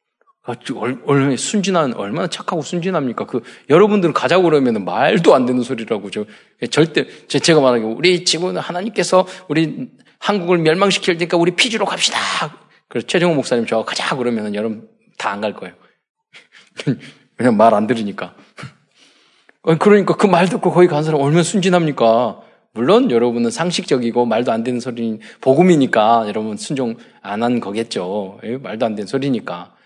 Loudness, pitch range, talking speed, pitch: -16 LUFS, 120-185 Hz, 345 characters per minute, 165 Hz